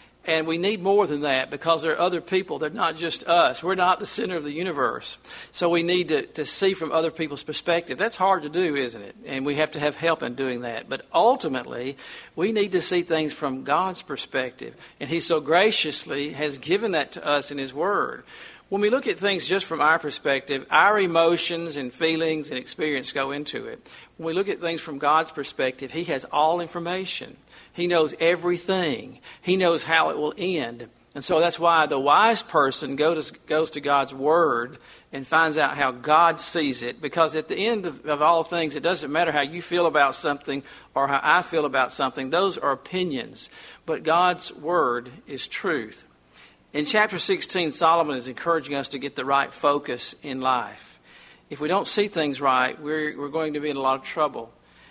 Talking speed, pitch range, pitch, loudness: 200 wpm, 140-175 Hz, 160 Hz, -24 LUFS